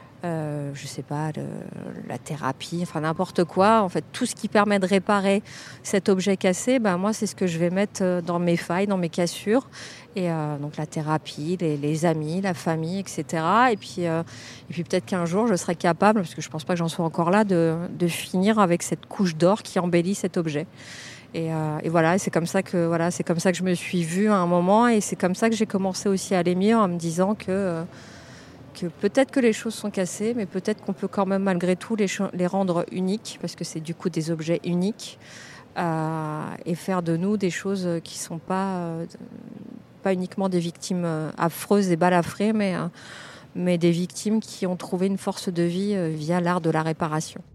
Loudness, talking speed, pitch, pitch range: -24 LUFS, 220 wpm, 180 Hz, 165-195 Hz